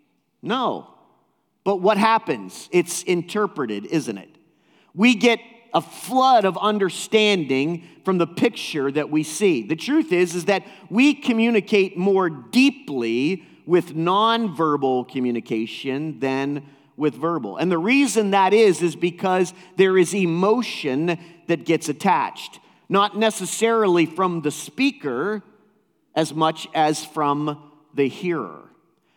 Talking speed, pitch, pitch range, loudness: 120 wpm, 180 Hz, 155-210 Hz, -21 LUFS